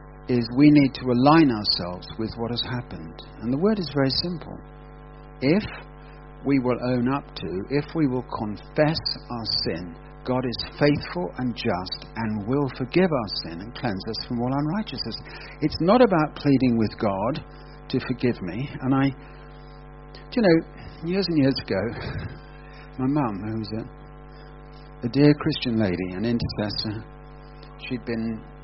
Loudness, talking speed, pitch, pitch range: -24 LUFS, 155 wpm, 125 Hz, 110-145 Hz